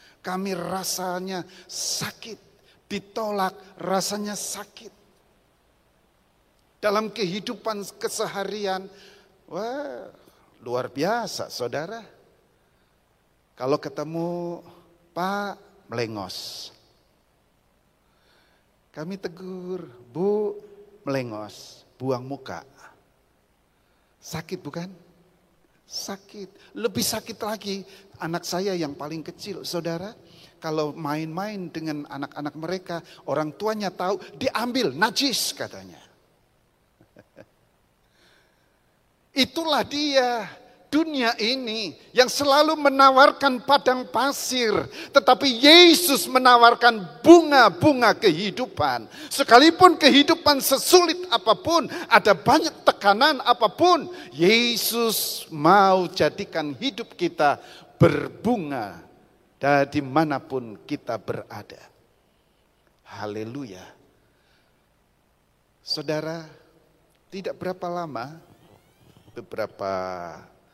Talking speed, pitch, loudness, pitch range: 70 wpm, 195 Hz, -21 LUFS, 160-240 Hz